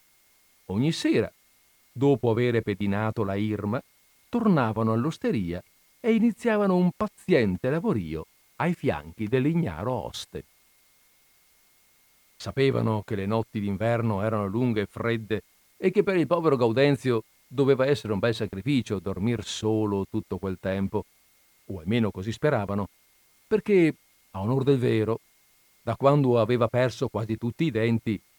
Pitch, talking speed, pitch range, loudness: 115 Hz, 125 wpm, 105-140 Hz, -26 LUFS